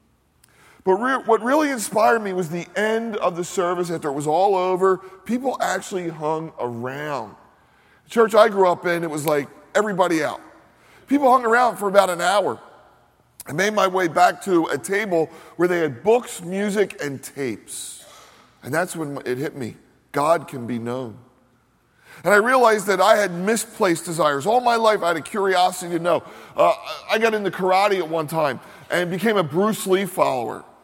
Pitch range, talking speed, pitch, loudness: 165-215 Hz, 185 wpm, 185 Hz, -21 LUFS